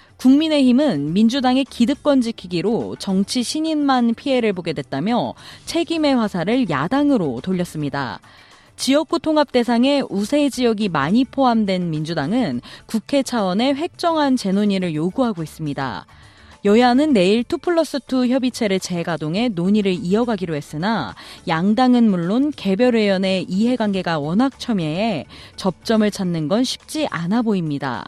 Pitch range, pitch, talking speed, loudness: 185-260 Hz, 225 Hz, 315 characters per minute, -19 LUFS